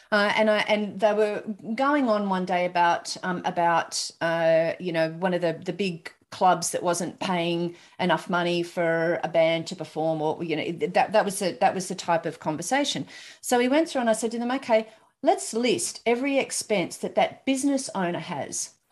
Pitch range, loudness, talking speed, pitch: 170-220 Hz, -25 LUFS, 205 wpm, 185 Hz